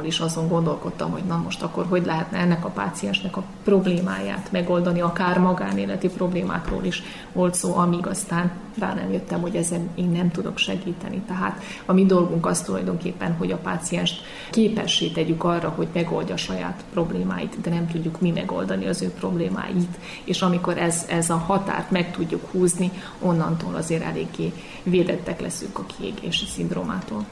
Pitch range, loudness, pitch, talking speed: 170-185 Hz, -24 LUFS, 175 Hz, 165 wpm